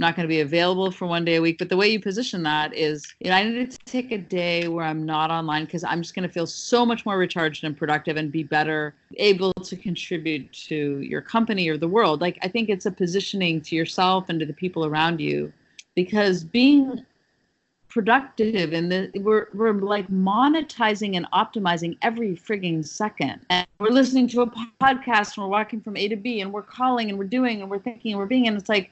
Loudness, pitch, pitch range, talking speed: -23 LUFS, 190 Hz, 165-220 Hz, 225 wpm